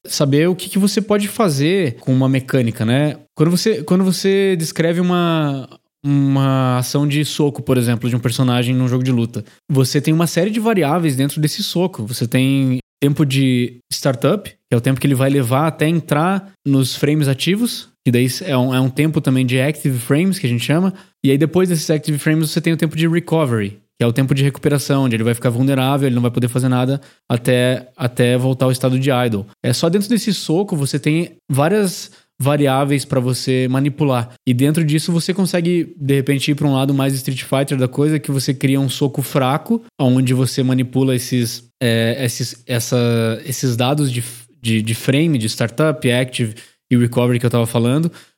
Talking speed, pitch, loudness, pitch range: 205 wpm, 135 Hz, -17 LUFS, 125-155 Hz